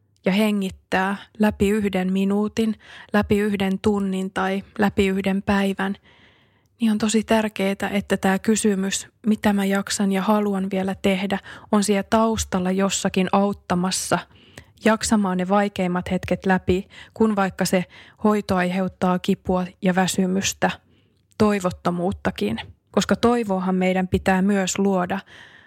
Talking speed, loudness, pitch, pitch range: 120 wpm, -22 LUFS, 195 Hz, 190-210 Hz